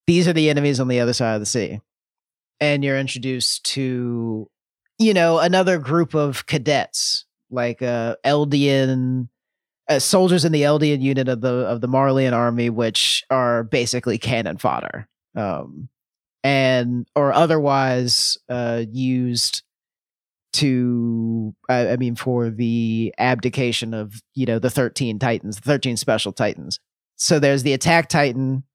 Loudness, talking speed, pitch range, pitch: -20 LUFS, 145 wpm, 120-140 Hz, 125 Hz